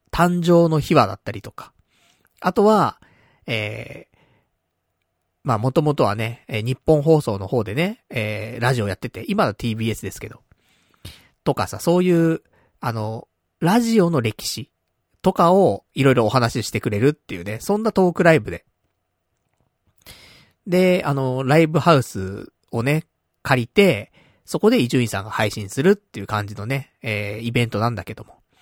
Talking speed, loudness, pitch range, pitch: 305 characters per minute, -20 LUFS, 105-160 Hz, 120 Hz